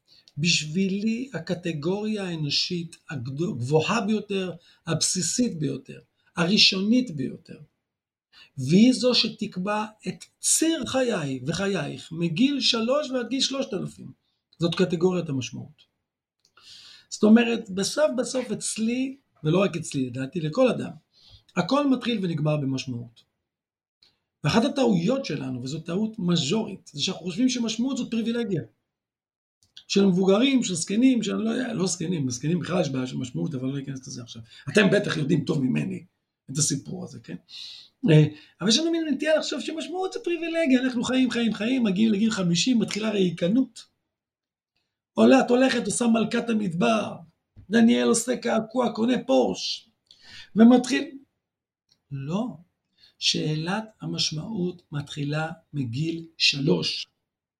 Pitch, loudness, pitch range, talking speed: 195 Hz, -24 LUFS, 160-240 Hz, 120 wpm